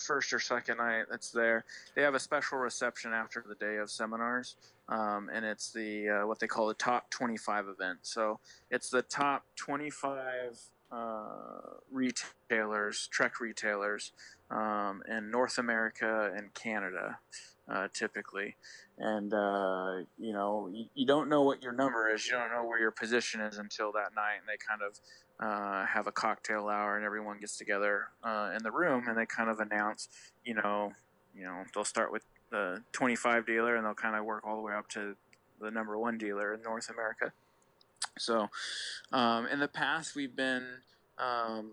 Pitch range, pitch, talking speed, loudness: 105-120 Hz, 110 Hz, 180 wpm, -34 LUFS